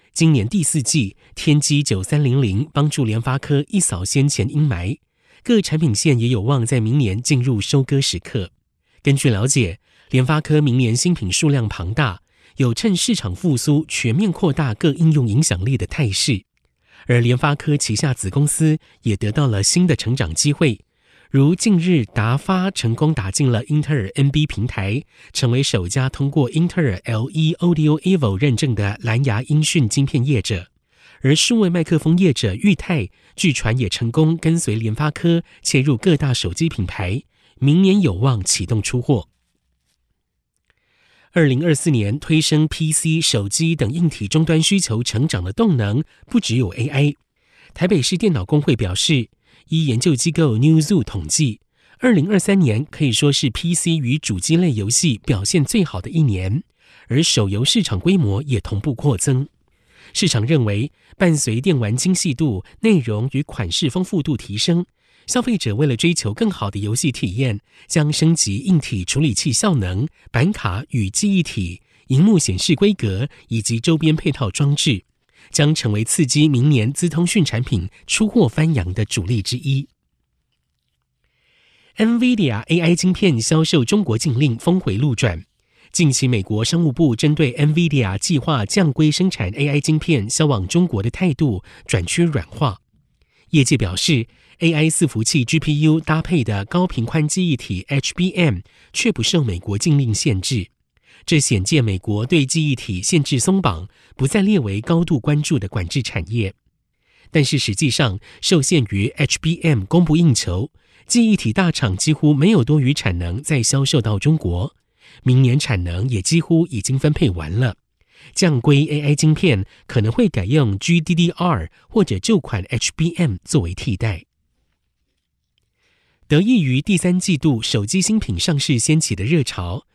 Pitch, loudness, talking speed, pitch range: 145 Hz, -18 LUFS, 255 characters per minute, 115-160 Hz